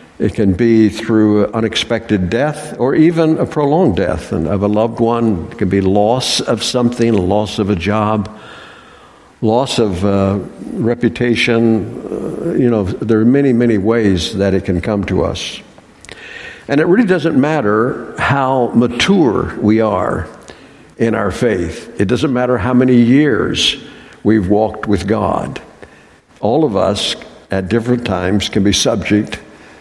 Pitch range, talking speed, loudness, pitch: 105-120 Hz, 150 wpm, -14 LUFS, 110 Hz